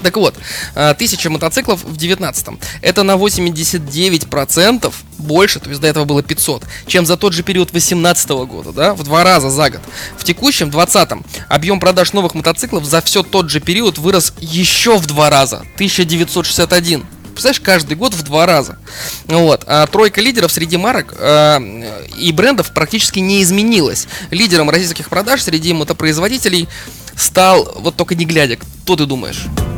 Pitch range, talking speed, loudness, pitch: 150-190 Hz, 155 wpm, -12 LUFS, 170 Hz